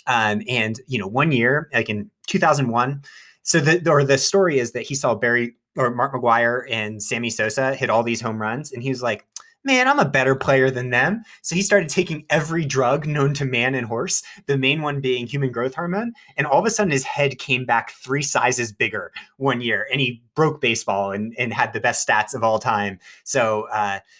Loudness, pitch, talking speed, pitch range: -20 LUFS, 130 Hz, 220 wpm, 120-150 Hz